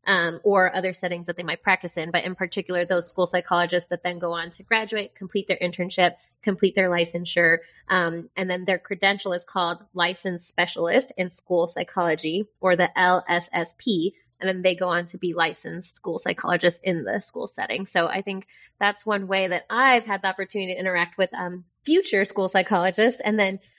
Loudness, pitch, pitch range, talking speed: -24 LUFS, 185 Hz, 175-195 Hz, 190 wpm